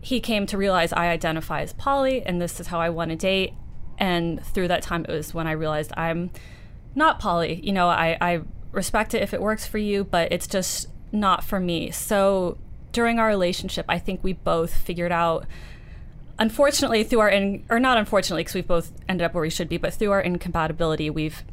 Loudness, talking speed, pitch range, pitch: -24 LUFS, 210 wpm, 165-205 Hz, 180 Hz